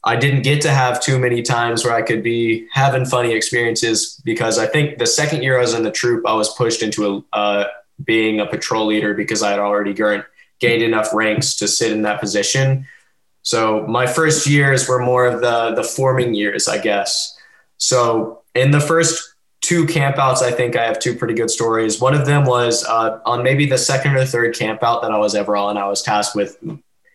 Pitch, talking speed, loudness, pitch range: 120 Hz, 210 wpm, -17 LUFS, 110-135 Hz